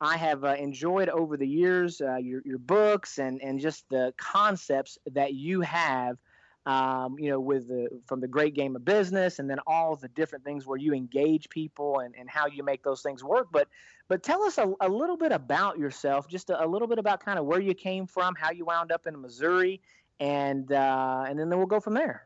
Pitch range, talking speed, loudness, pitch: 135-185 Hz, 225 wpm, -28 LUFS, 150 Hz